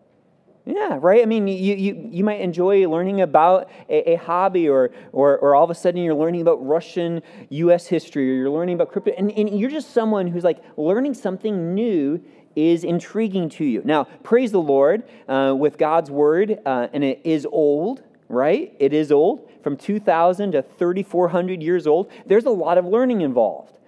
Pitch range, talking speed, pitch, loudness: 155-205 Hz, 190 wpm, 175 Hz, -20 LUFS